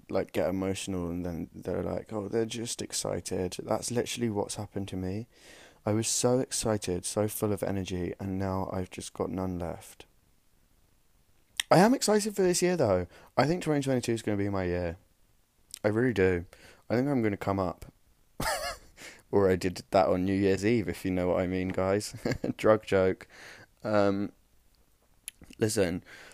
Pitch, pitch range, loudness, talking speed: 100 Hz, 95-115 Hz, -30 LUFS, 175 wpm